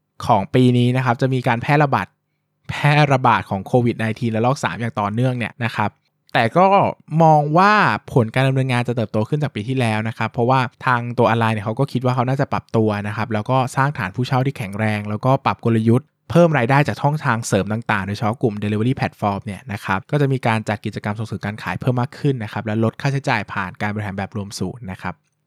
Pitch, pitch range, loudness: 120 Hz, 105-135 Hz, -19 LUFS